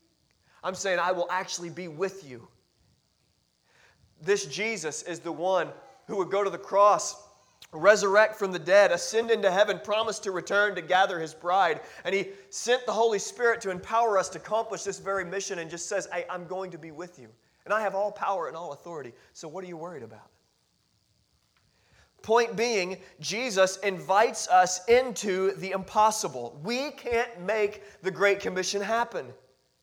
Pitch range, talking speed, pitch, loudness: 180-215 Hz, 175 wpm, 195 Hz, -27 LUFS